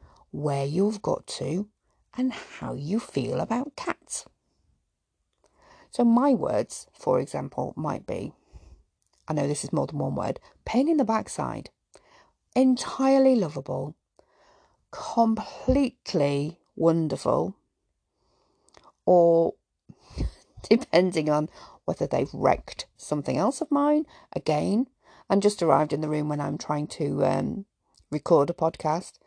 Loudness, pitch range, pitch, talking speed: -26 LUFS, 150-255 Hz, 185 Hz, 120 wpm